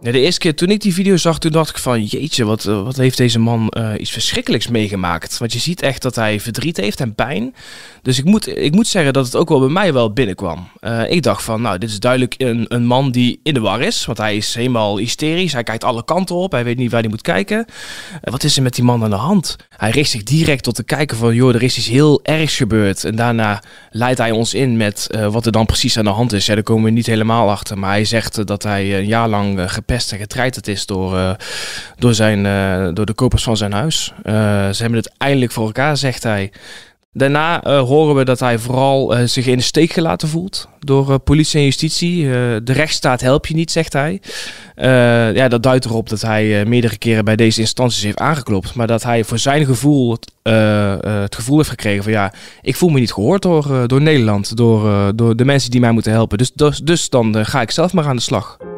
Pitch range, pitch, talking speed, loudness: 110-140 Hz, 120 Hz, 250 wpm, -15 LUFS